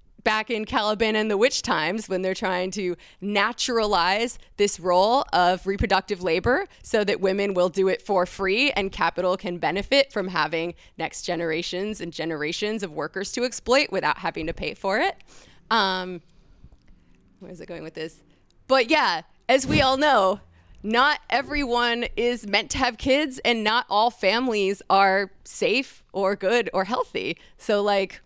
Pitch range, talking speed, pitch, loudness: 180-235 Hz, 165 wpm, 200 Hz, -23 LUFS